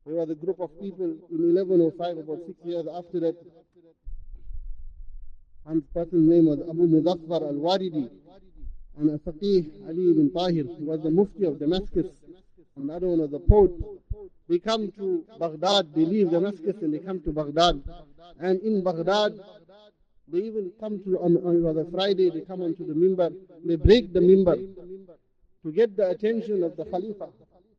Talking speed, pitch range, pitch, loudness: 170 wpm, 160-195 Hz, 175 Hz, -25 LUFS